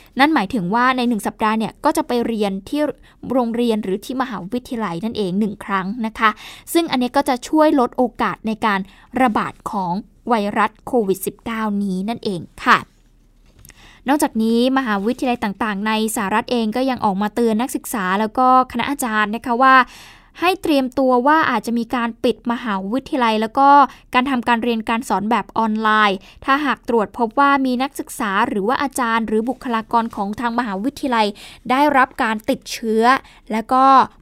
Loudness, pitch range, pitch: -18 LUFS, 220-260 Hz, 235 Hz